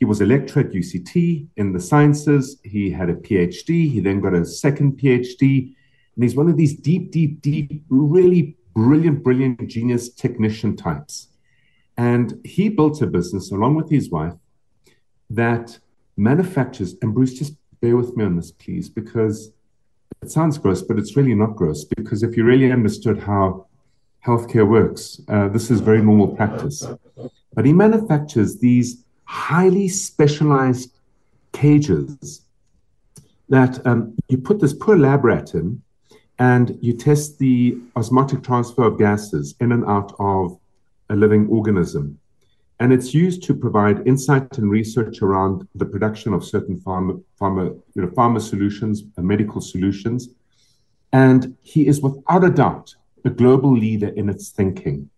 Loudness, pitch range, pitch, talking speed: -18 LUFS, 105-135 Hz, 120 Hz, 155 wpm